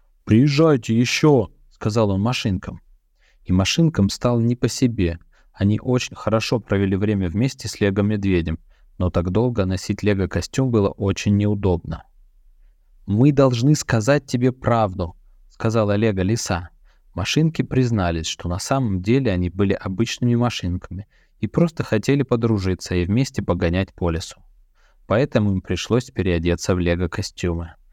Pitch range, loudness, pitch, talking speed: 90-120 Hz, -20 LUFS, 105 Hz, 130 wpm